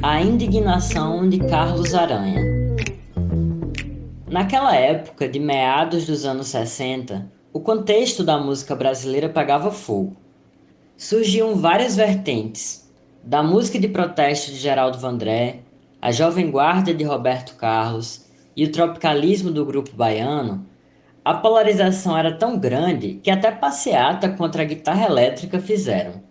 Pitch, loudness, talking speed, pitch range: 150 Hz, -20 LUFS, 125 wpm, 130-185 Hz